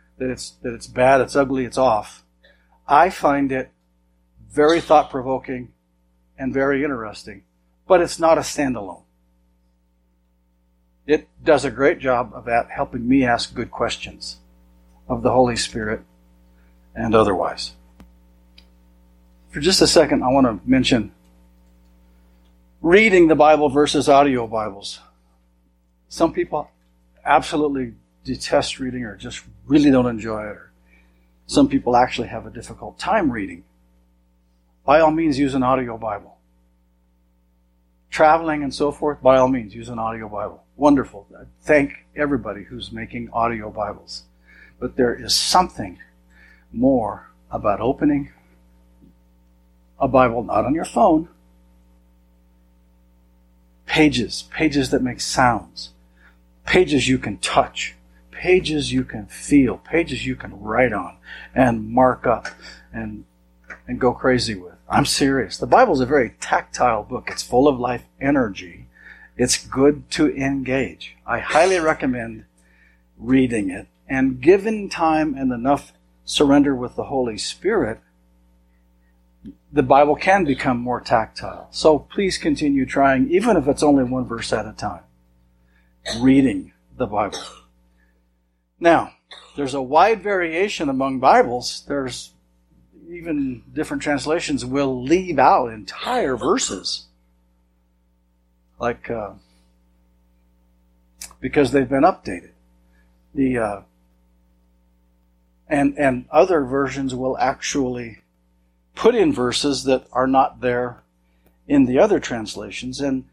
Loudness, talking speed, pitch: -19 LUFS, 125 wpm, 110 Hz